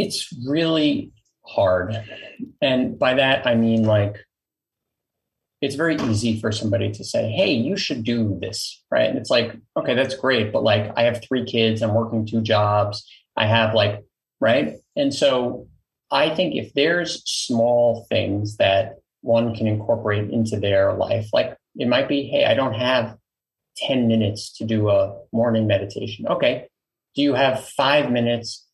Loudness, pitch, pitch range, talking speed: -21 LUFS, 115 Hz, 105-125 Hz, 165 wpm